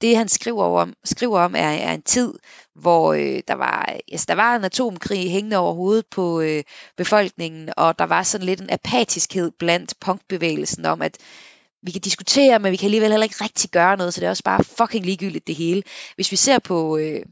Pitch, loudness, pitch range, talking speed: 190 Hz, -20 LUFS, 170-220 Hz, 215 wpm